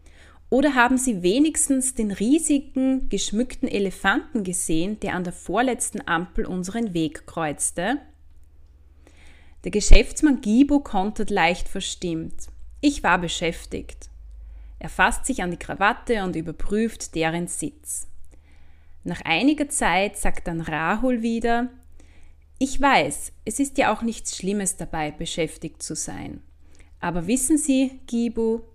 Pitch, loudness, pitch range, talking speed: 190 Hz, -23 LUFS, 150-240 Hz, 125 wpm